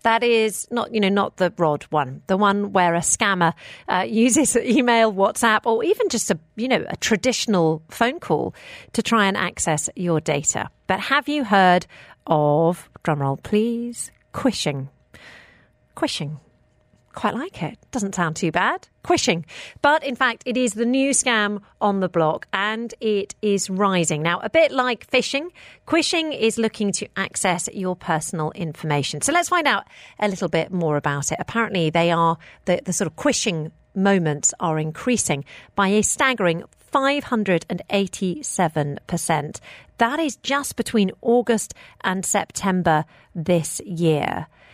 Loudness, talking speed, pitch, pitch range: -21 LUFS, 150 wpm, 200 Hz, 165-235 Hz